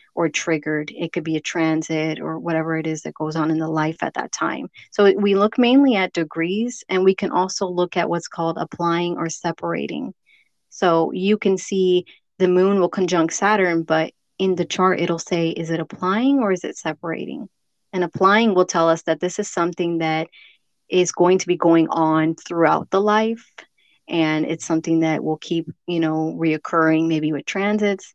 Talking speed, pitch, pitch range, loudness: 195 wpm, 170 Hz, 160-185 Hz, -20 LUFS